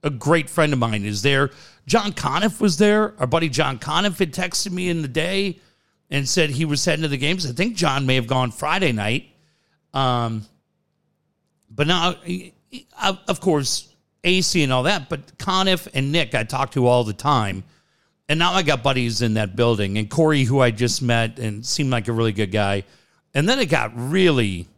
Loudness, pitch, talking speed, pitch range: -20 LUFS, 145 Hz, 200 wpm, 125-175 Hz